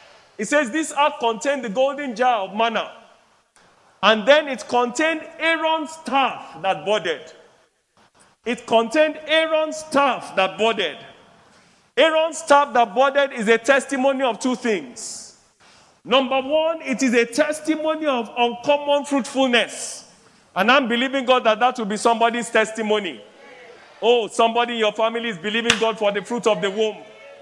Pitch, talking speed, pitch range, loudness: 250 Hz, 145 wpm, 225-285 Hz, -20 LUFS